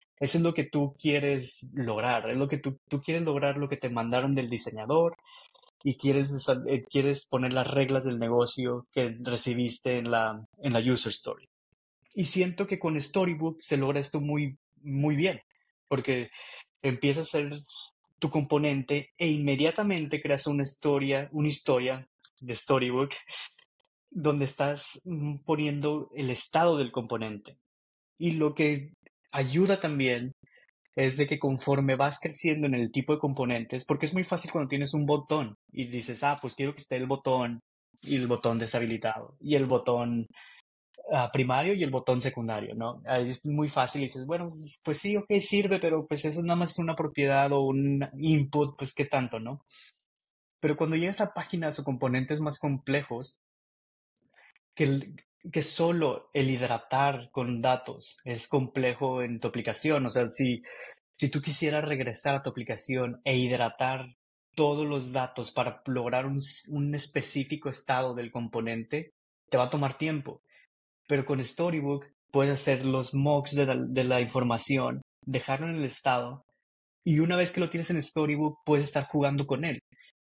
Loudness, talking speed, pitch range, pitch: -29 LUFS, 165 wpm, 130-150 Hz, 140 Hz